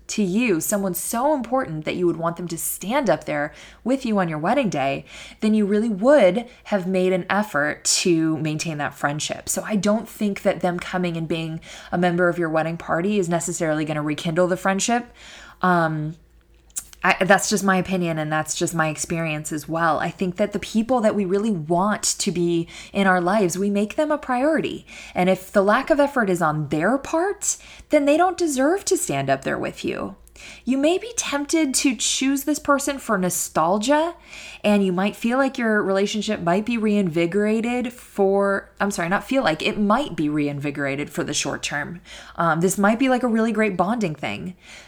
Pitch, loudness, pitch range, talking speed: 195 Hz, -22 LUFS, 170-235 Hz, 200 wpm